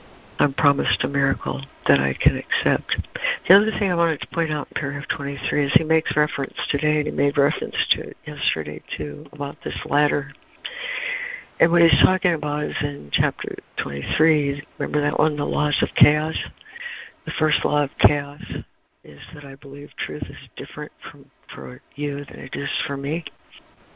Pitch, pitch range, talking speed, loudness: 150 Hz, 140-165 Hz, 180 wpm, -22 LUFS